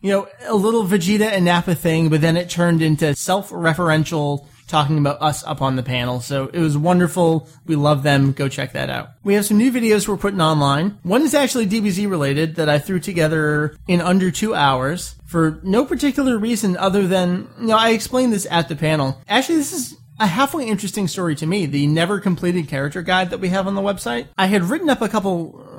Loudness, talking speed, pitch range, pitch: -18 LUFS, 215 wpm, 155-205 Hz, 175 Hz